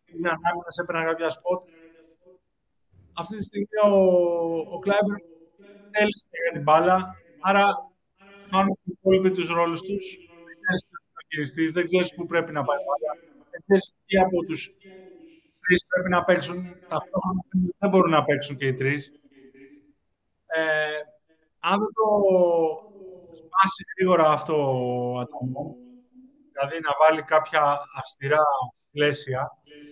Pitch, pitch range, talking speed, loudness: 170 Hz, 150-190 Hz, 130 wpm, -24 LUFS